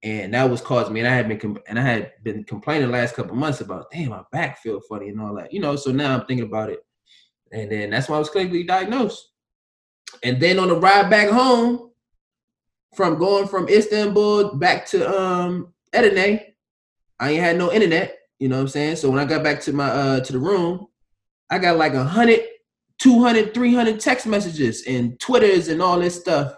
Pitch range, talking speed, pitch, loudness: 120-200 Hz, 215 wpm, 155 Hz, -19 LUFS